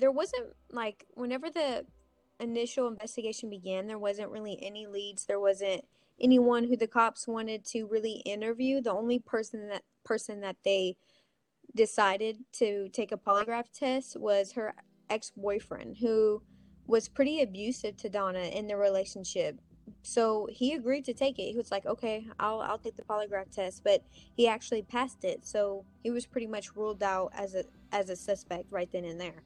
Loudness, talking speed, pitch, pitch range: -32 LUFS, 175 wpm, 220 Hz, 200-240 Hz